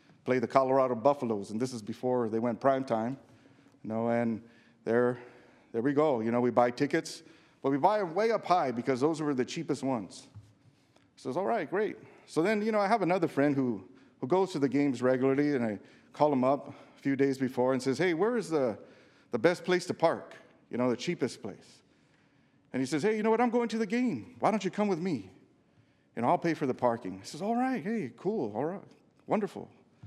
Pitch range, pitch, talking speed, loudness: 125-170 Hz, 135 Hz, 230 wpm, -30 LUFS